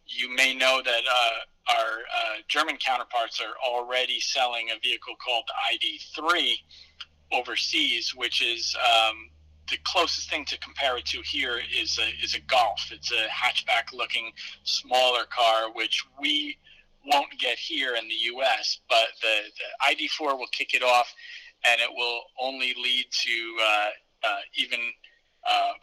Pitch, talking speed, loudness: 130 Hz, 150 wpm, -25 LUFS